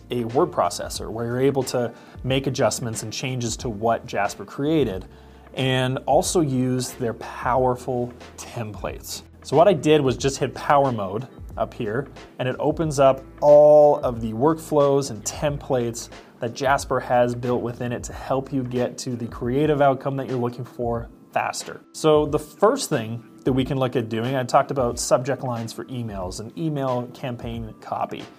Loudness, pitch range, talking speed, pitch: -22 LUFS, 115-140 Hz, 175 wpm, 125 Hz